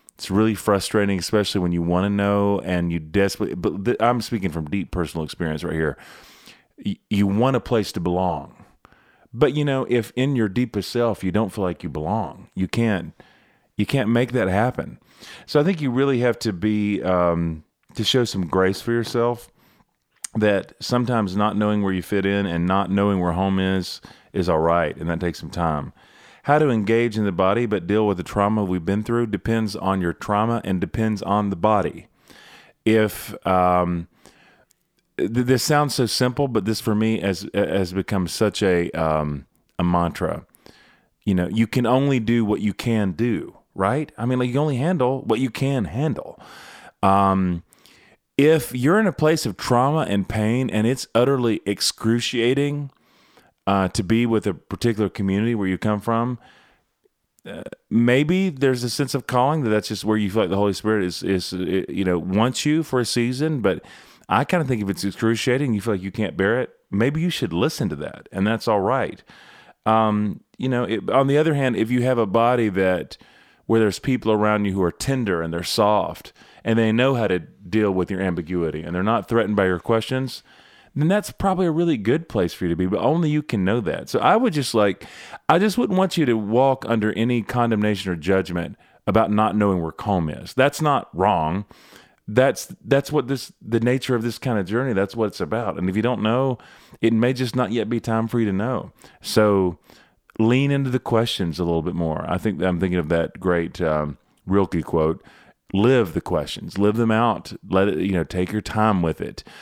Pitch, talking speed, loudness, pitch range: 110 Hz, 205 wpm, -22 LUFS, 95-125 Hz